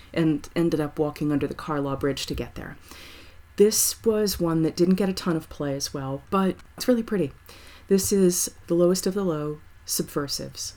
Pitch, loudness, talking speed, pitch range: 155 Hz, -25 LUFS, 195 wpm, 135-185 Hz